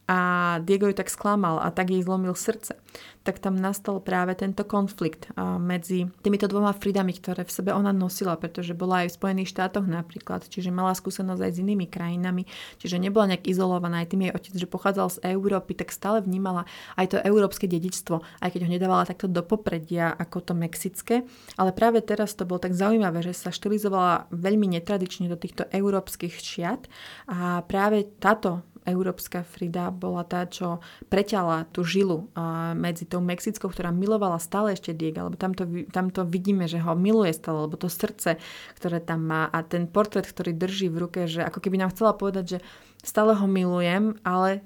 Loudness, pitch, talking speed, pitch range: -26 LUFS, 185 Hz, 180 wpm, 175-200 Hz